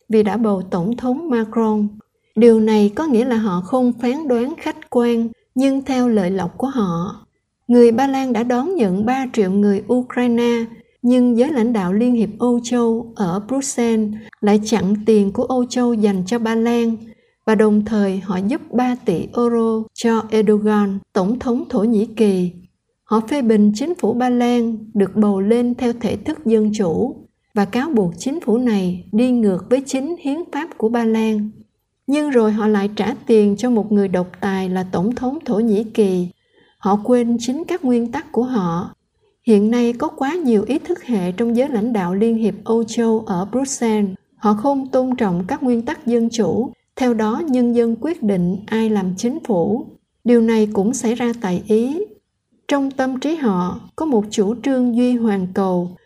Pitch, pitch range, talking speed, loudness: 230 Hz, 210-245 Hz, 190 wpm, -18 LUFS